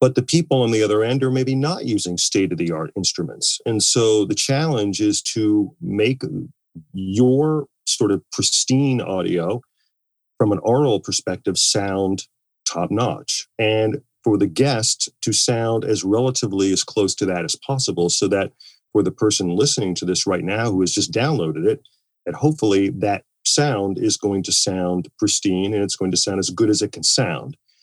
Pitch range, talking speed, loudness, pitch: 95-130 Hz, 180 wpm, -19 LUFS, 105 Hz